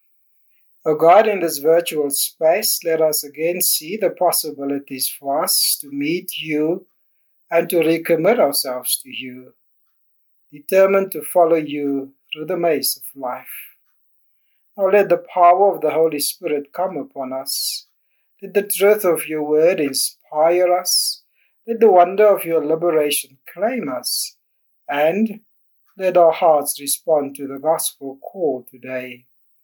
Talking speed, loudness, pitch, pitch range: 145 wpm, -18 LUFS, 160 Hz, 145-180 Hz